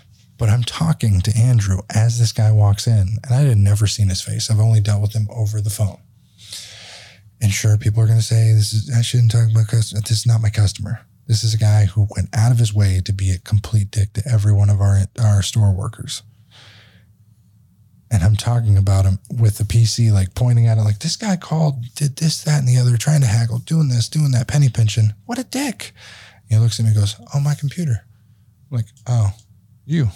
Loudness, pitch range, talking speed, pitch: -17 LUFS, 105-120 Hz, 225 wpm, 110 Hz